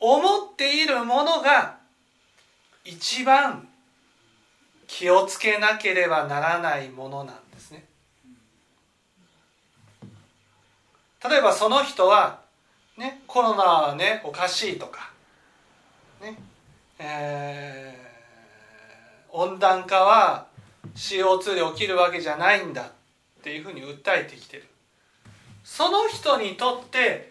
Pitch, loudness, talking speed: 185 Hz, -21 LUFS, 195 characters per minute